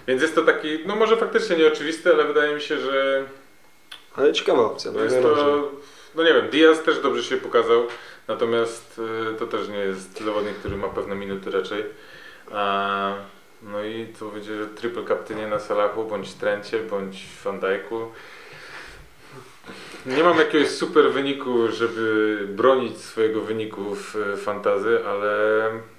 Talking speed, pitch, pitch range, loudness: 145 wpm, 115 Hz, 105-155 Hz, -22 LUFS